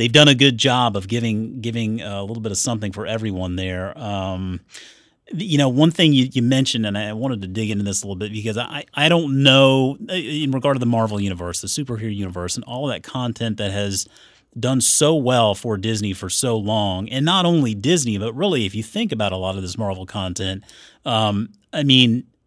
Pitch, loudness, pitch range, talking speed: 115 Hz, -19 LUFS, 100-135 Hz, 215 wpm